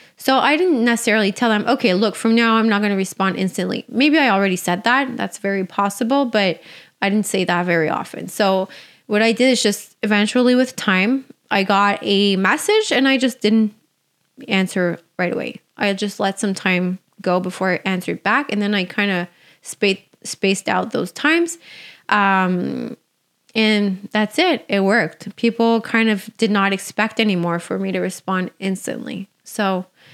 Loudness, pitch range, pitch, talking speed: -18 LUFS, 190-230 Hz, 205 Hz, 180 wpm